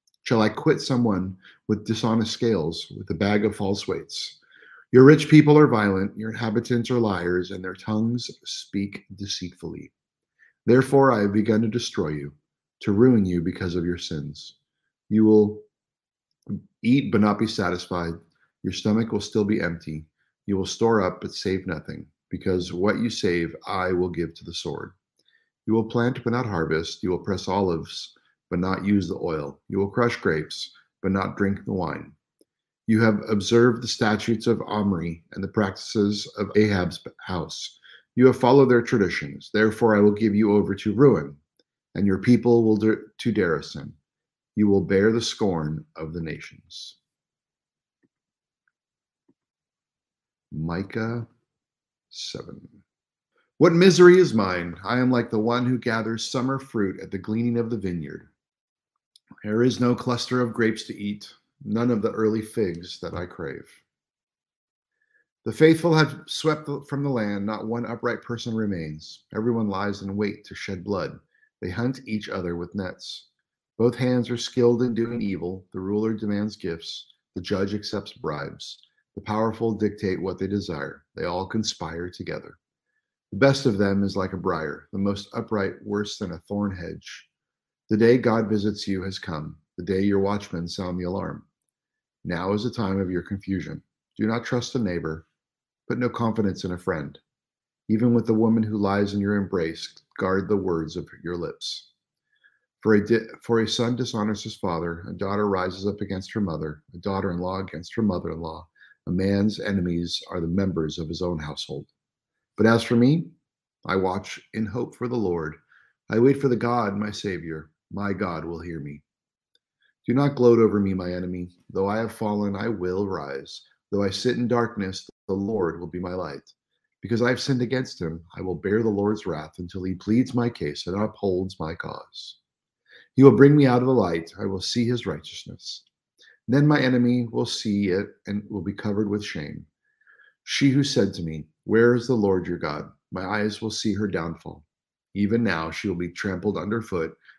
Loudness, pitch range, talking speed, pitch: -24 LUFS, 95-115 Hz, 175 wpm, 105 Hz